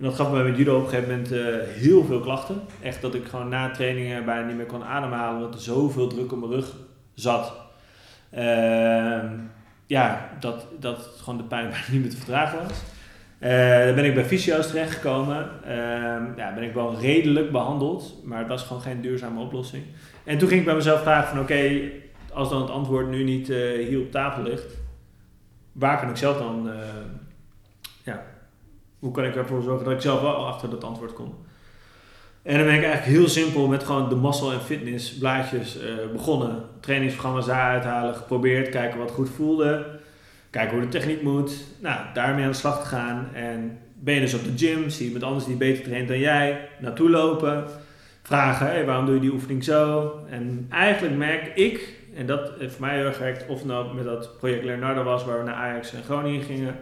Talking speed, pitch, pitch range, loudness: 205 wpm, 130 Hz, 120-140 Hz, -24 LUFS